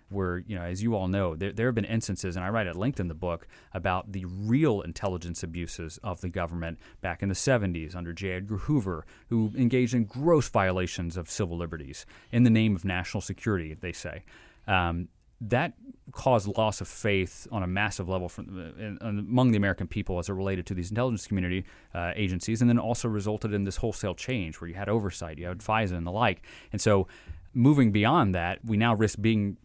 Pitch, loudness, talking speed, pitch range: 100 Hz, -28 LUFS, 215 wpm, 90-110 Hz